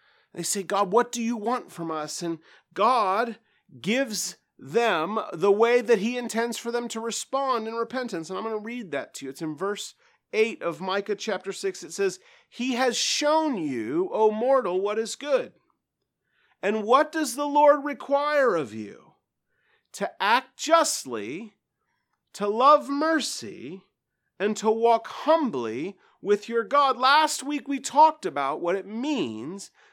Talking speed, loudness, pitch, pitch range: 160 wpm, -25 LUFS, 235 Hz, 205-290 Hz